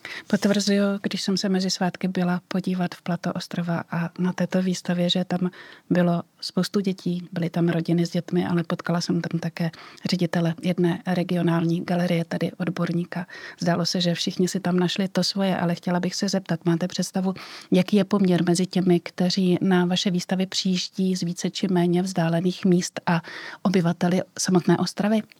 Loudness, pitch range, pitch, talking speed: -24 LUFS, 175-185 Hz, 180 Hz, 170 wpm